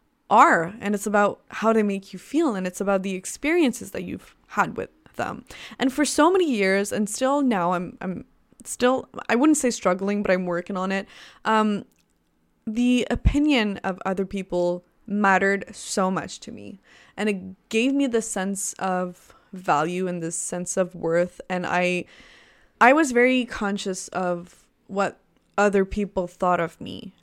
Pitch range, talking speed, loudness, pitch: 185-230 Hz, 165 wpm, -23 LUFS, 195 Hz